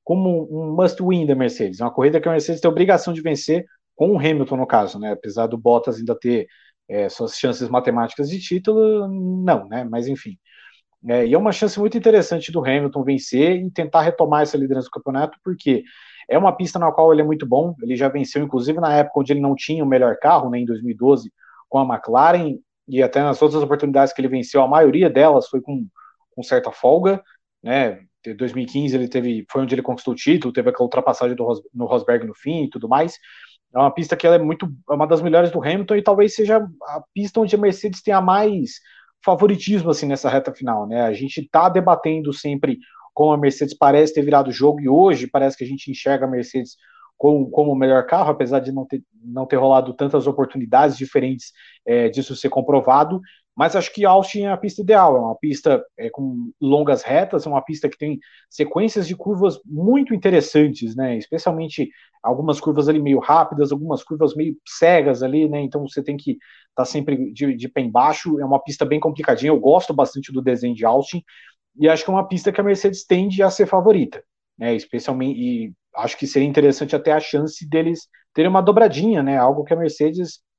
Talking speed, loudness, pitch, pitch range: 210 wpm, -18 LUFS, 150 Hz, 135-175 Hz